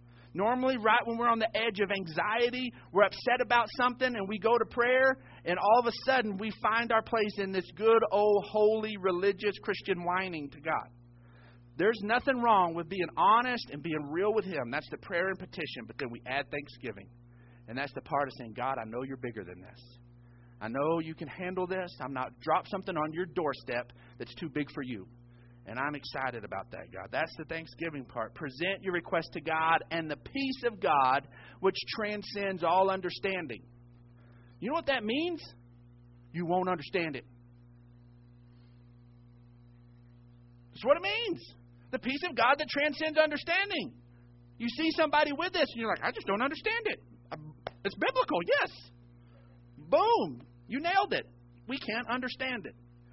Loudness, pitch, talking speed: -31 LUFS, 165 Hz, 175 wpm